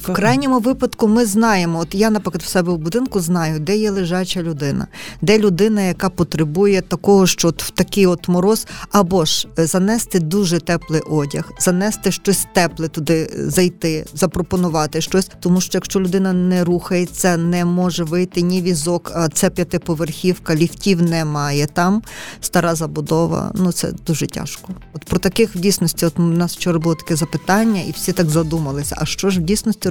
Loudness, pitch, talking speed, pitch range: -17 LUFS, 180 Hz, 170 wpm, 165-195 Hz